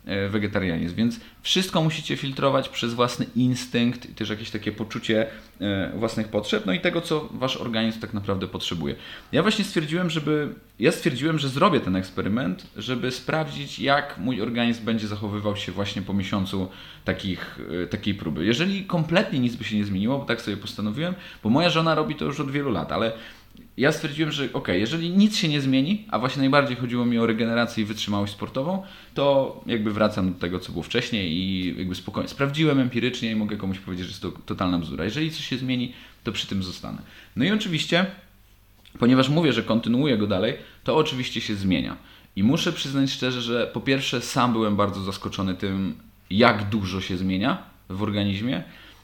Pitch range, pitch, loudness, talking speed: 100-140 Hz, 115 Hz, -25 LUFS, 180 wpm